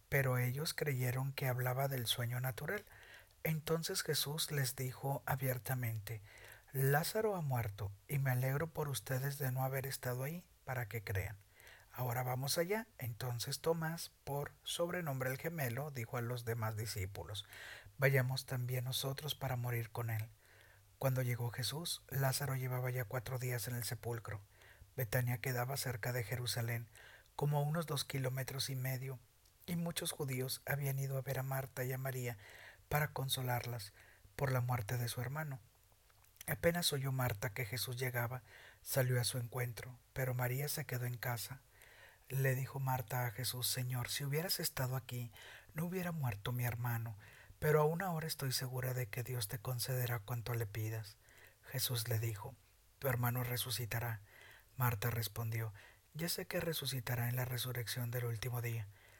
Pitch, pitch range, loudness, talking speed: 125 Hz, 120-135 Hz, -39 LUFS, 155 wpm